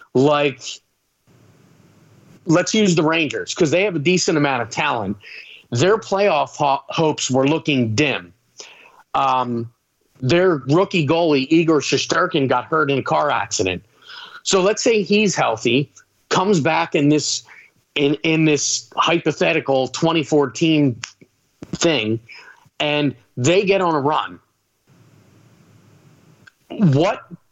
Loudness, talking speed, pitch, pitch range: -18 LUFS, 120 wpm, 150 Hz, 130-170 Hz